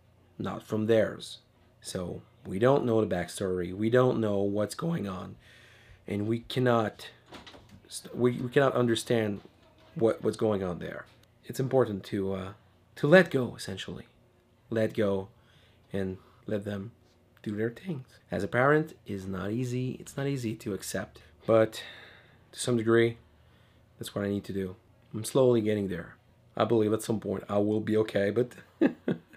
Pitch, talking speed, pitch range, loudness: 110 Hz, 160 wpm, 100-120 Hz, -29 LUFS